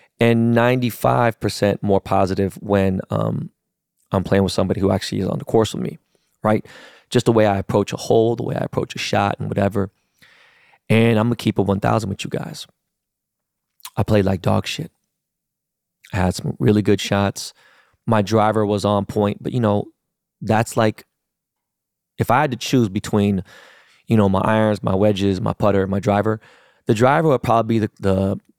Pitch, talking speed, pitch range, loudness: 105 Hz, 185 wpm, 100-115 Hz, -19 LUFS